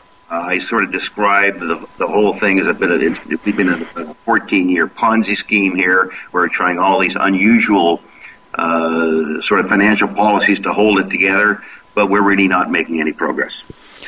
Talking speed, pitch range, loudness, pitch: 190 wpm, 90-105 Hz, -14 LUFS, 95 Hz